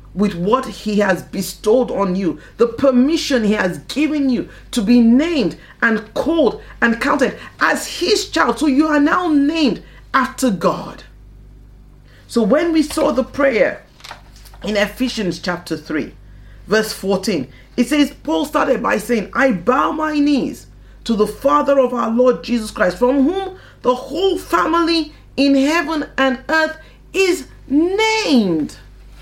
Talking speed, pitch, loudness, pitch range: 145 wpm, 260 Hz, -17 LUFS, 215-300 Hz